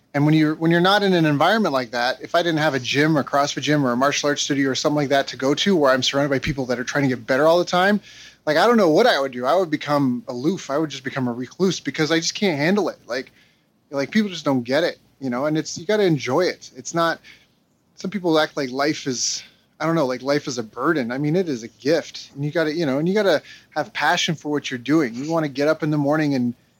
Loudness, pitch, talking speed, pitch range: -21 LUFS, 150 Hz, 300 wpm, 135-165 Hz